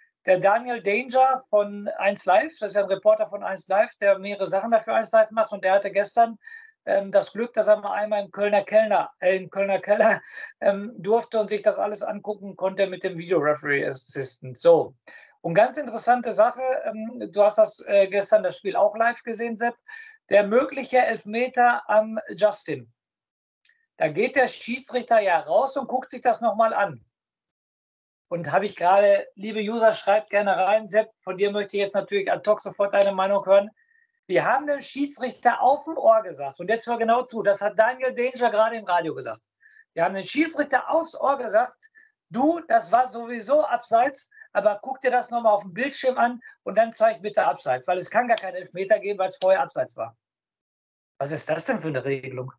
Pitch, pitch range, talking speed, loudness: 220 Hz, 200-265 Hz, 195 wpm, -23 LUFS